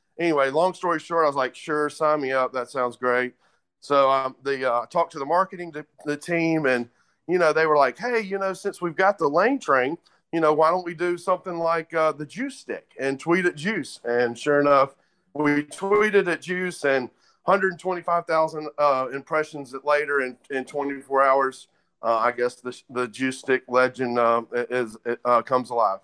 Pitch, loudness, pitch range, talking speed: 145 Hz, -23 LUFS, 130-175 Hz, 195 wpm